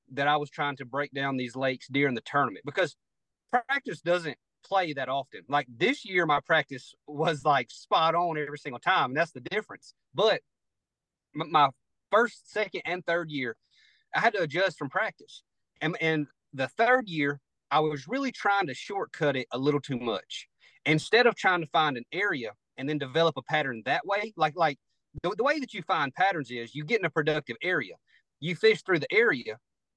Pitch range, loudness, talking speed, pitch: 140-180 Hz, -28 LUFS, 195 wpm, 155 Hz